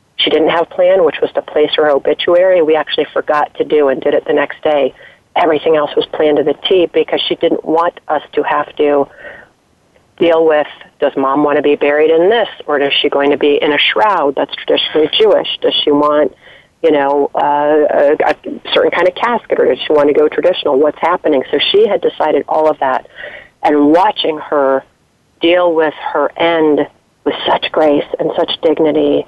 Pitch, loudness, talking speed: 160 Hz, -12 LUFS, 205 wpm